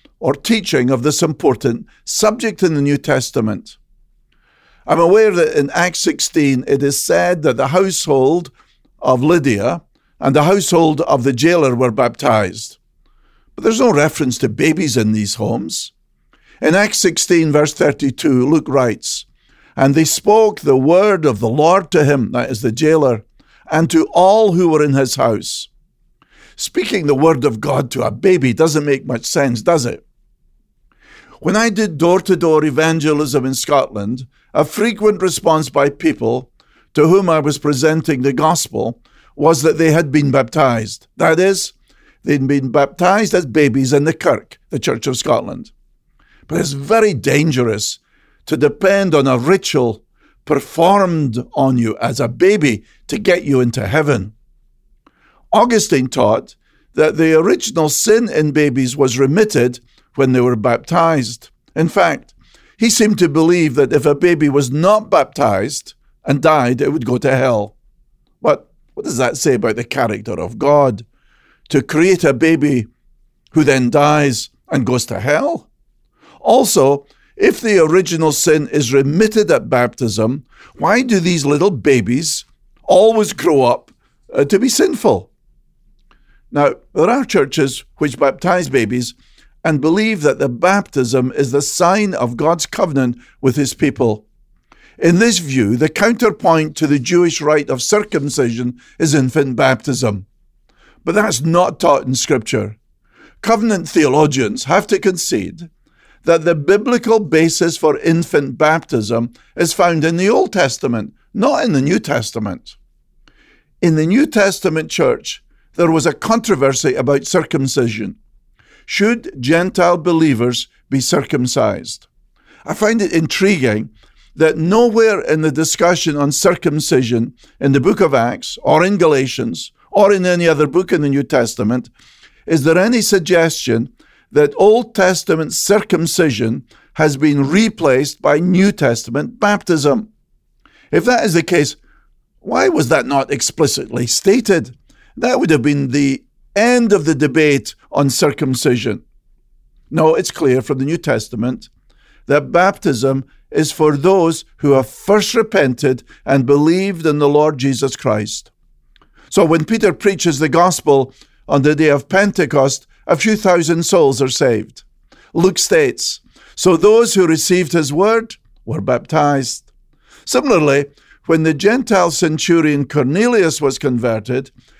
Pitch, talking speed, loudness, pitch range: 155 Hz, 145 wpm, -14 LUFS, 135-180 Hz